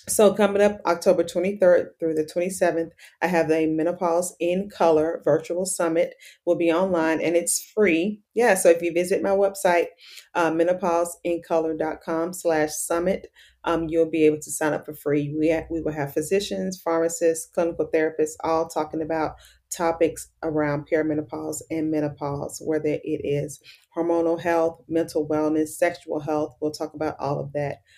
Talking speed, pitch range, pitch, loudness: 160 wpm, 155-175 Hz, 165 Hz, -24 LUFS